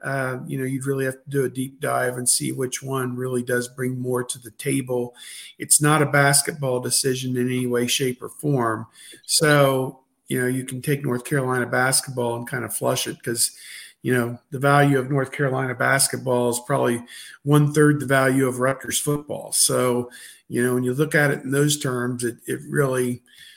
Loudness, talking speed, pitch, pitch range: -22 LUFS, 200 wpm, 130 Hz, 125-140 Hz